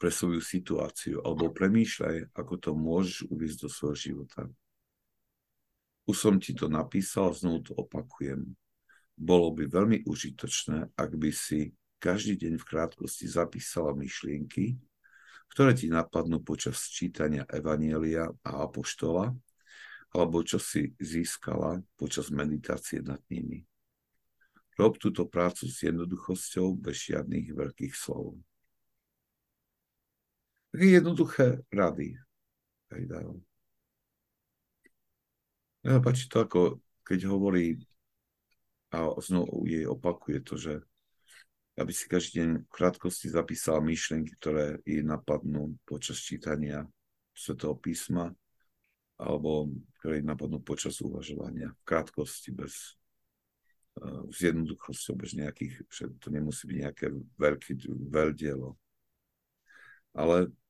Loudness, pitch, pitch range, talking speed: -31 LUFS, 80 Hz, 75-90 Hz, 105 wpm